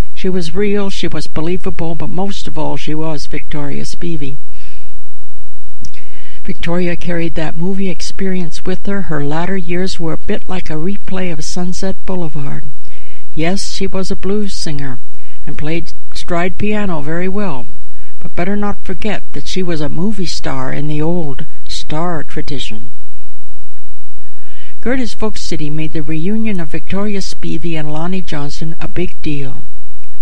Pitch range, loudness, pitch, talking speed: 135-185 Hz, -21 LUFS, 165 Hz, 150 wpm